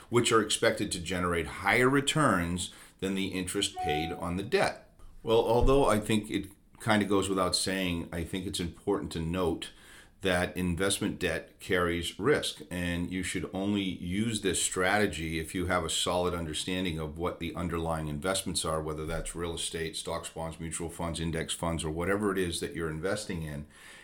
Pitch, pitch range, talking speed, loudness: 90 Hz, 80-95 Hz, 180 wpm, -30 LUFS